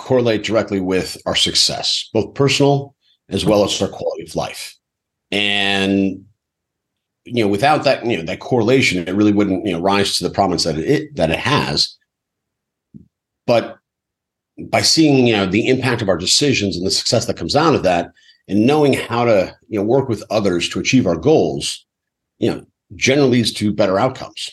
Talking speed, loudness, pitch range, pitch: 185 wpm, -16 LUFS, 95-130 Hz, 105 Hz